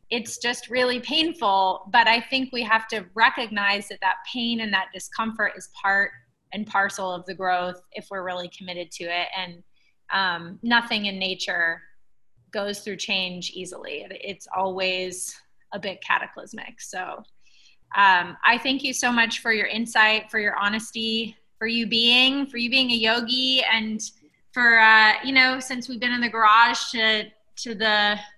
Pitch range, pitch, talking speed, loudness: 190-235 Hz, 220 Hz, 165 wpm, -21 LUFS